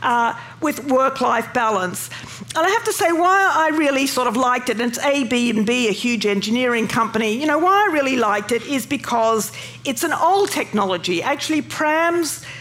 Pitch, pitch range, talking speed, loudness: 250 Hz, 230-305 Hz, 200 wpm, -19 LUFS